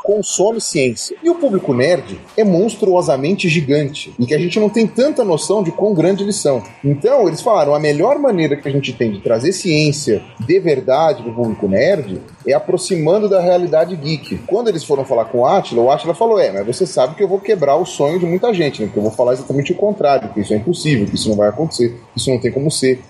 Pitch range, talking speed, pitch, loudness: 130-195 Hz, 240 wpm, 155 Hz, -15 LUFS